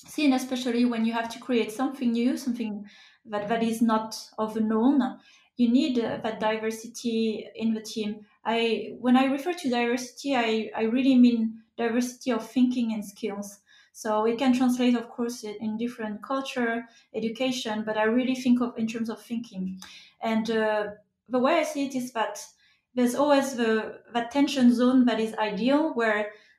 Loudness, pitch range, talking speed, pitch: -26 LUFS, 220-250 Hz, 175 wpm, 230 Hz